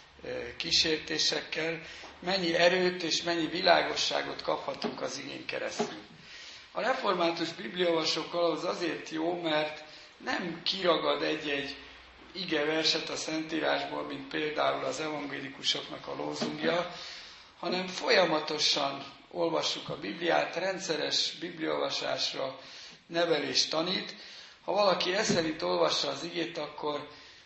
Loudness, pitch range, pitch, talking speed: -30 LUFS, 155-170 Hz, 160 Hz, 100 wpm